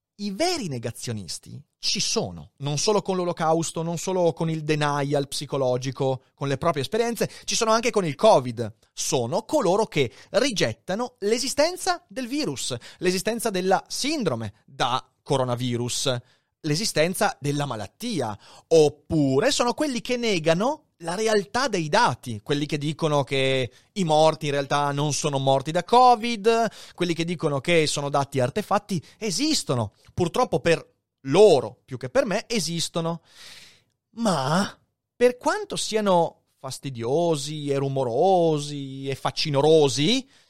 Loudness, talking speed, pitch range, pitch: -24 LUFS, 130 wpm, 140-210 Hz, 160 Hz